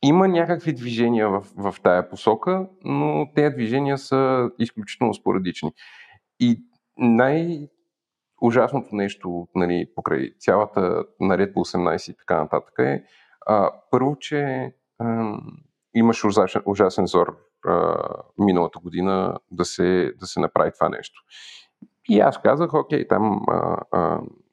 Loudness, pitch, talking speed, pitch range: -22 LUFS, 120 Hz, 125 wpm, 100-145 Hz